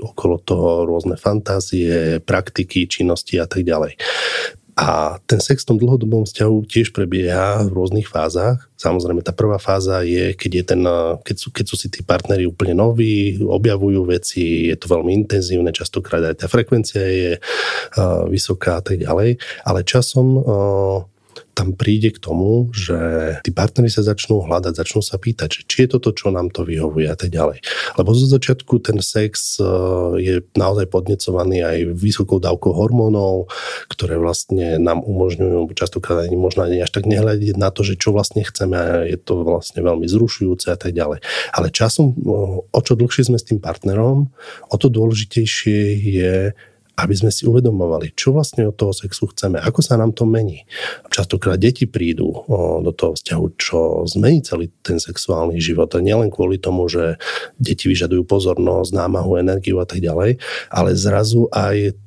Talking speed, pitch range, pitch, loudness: 170 wpm, 90-110 Hz, 100 Hz, -17 LUFS